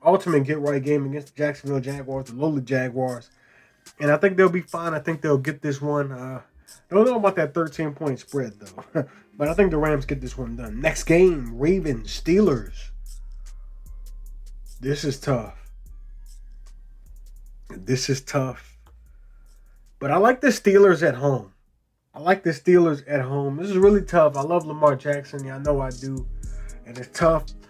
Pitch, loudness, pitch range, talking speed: 145 Hz, -22 LUFS, 130-160 Hz, 175 wpm